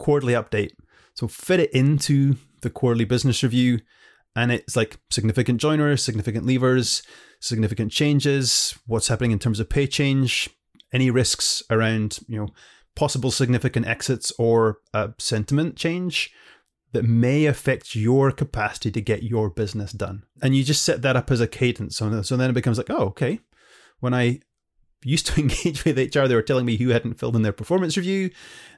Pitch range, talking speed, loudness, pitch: 115-135 Hz, 175 wpm, -22 LUFS, 125 Hz